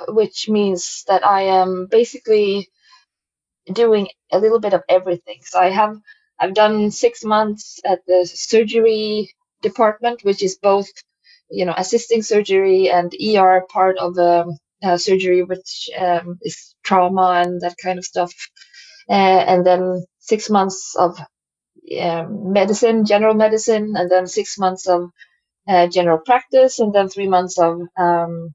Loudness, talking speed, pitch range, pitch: -17 LUFS, 145 wpm, 180-220 Hz, 195 Hz